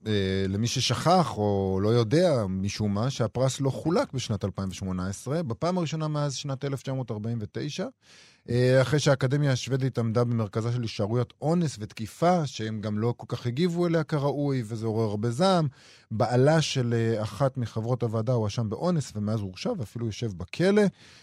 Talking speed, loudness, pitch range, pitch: 140 wpm, -27 LUFS, 110-145 Hz, 120 Hz